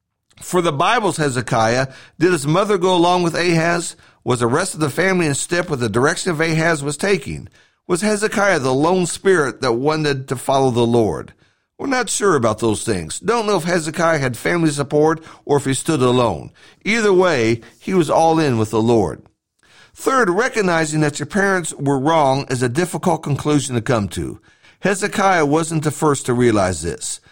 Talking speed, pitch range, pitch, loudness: 185 wpm, 130-180 Hz, 155 Hz, -17 LUFS